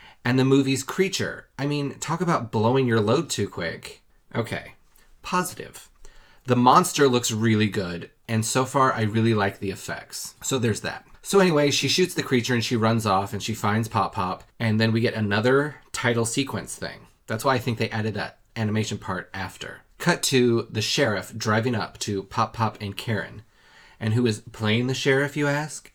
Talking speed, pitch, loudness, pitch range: 190 wpm, 115 Hz, -24 LUFS, 110-135 Hz